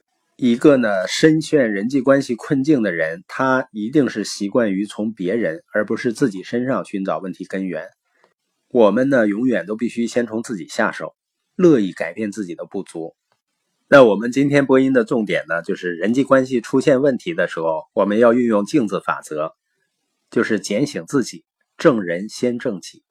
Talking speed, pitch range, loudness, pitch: 270 characters per minute, 105-135 Hz, -18 LUFS, 120 Hz